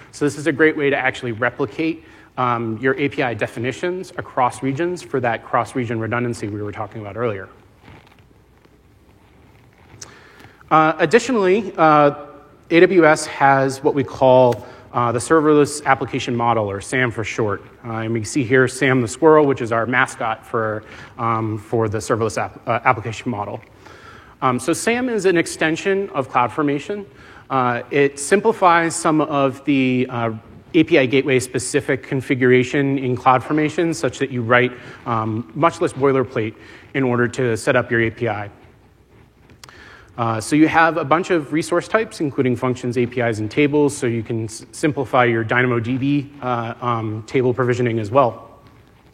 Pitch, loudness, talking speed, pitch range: 130 Hz, -18 LUFS, 155 wpm, 115-145 Hz